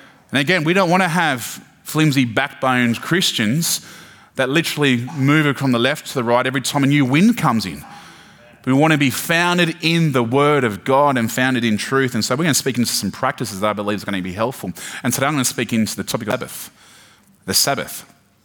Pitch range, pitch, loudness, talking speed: 120-155 Hz, 135 Hz, -18 LUFS, 230 wpm